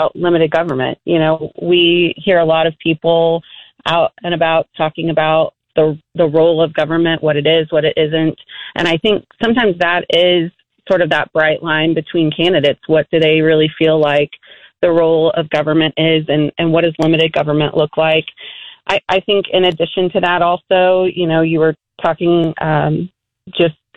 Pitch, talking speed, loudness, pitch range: 165 Hz, 185 wpm, -14 LUFS, 155-175 Hz